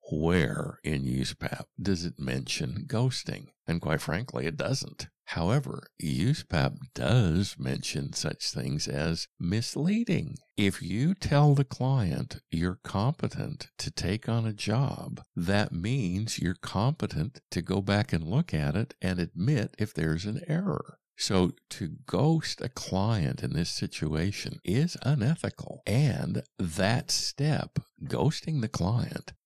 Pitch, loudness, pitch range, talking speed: 105 Hz, -30 LUFS, 90-140 Hz, 130 wpm